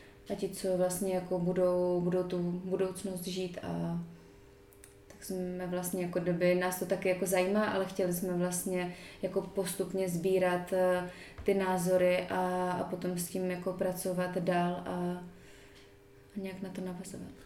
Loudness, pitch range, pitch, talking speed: -33 LUFS, 180-185 Hz, 180 Hz, 150 wpm